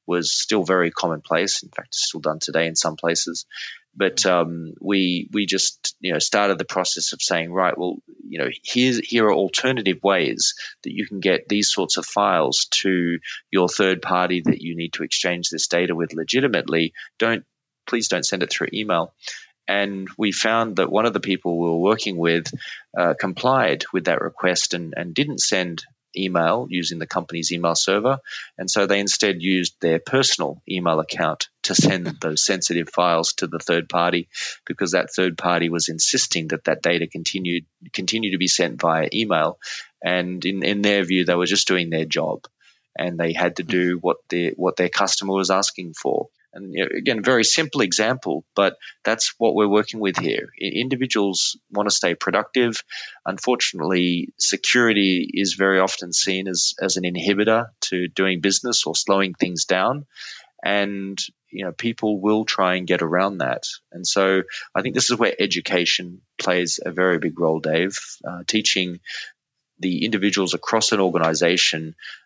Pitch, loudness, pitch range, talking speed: 90 Hz, -21 LUFS, 85-100 Hz, 175 wpm